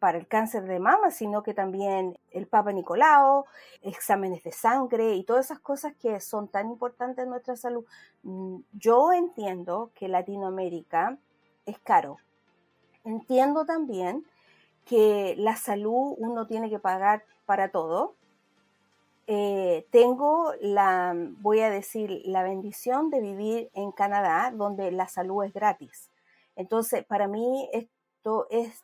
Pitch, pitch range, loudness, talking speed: 215 Hz, 195-245 Hz, -26 LUFS, 135 wpm